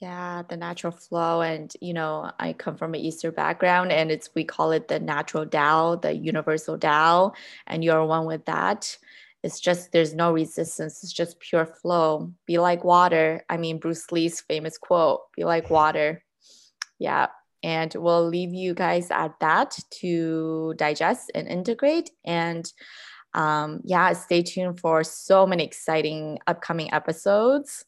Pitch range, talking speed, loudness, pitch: 160-175 Hz, 155 wpm, -24 LUFS, 165 Hz